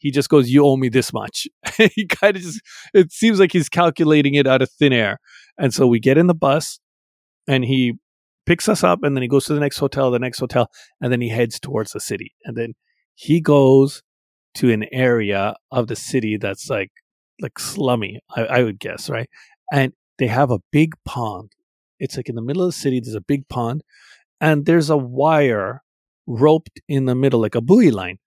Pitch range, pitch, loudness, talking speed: 120-155 Hz, 135 Hz, -18 LUFS, 215 wpm